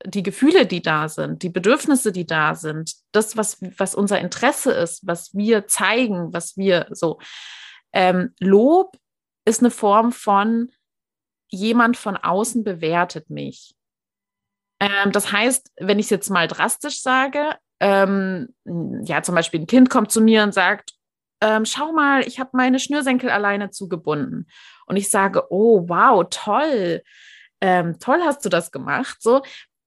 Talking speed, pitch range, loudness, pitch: 155 wpm, 180-240 Hz, -19 LUFS, 205 Hz